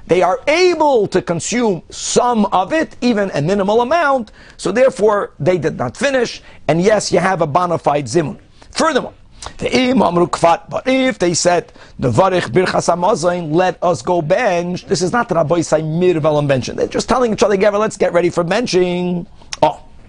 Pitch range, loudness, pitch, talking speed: 175-225 Hz, -15 LUFS, 185 Hz, 165 wpm